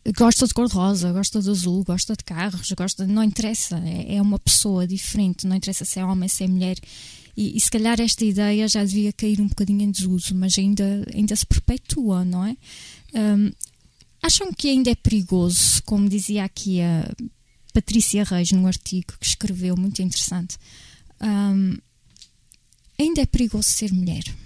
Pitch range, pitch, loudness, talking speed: 185-215 Hz, 200 Hz, -21 LUFS, 170 wpm